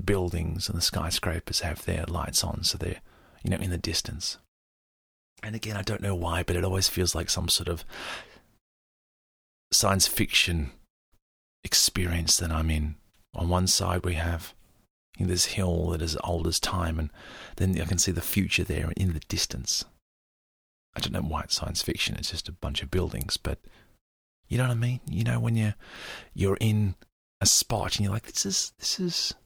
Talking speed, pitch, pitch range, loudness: 185 wpm, 90 Hz, 85-100 Hz, -27 LUFS